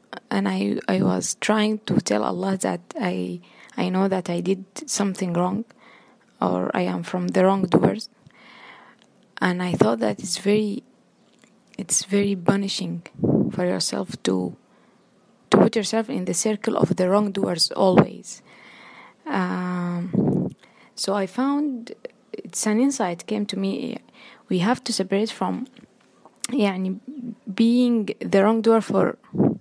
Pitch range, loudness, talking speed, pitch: 185-230 Hz, -23 LUFS, 130 wpm, 205 Hz